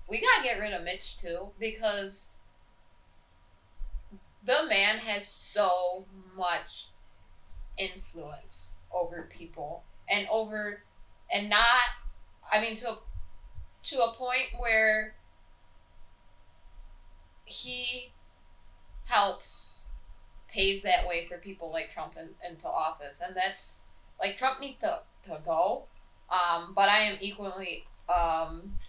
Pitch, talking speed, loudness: 180 Hz, 110 wpm, -29 LUFS